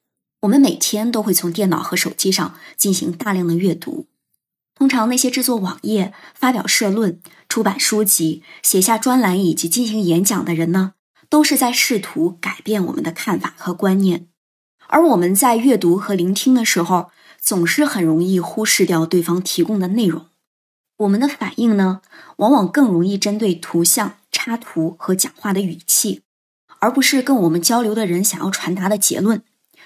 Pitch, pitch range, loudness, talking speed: 200 Hz, 175-230 Hz, -17 LUFS, 265 characters per minute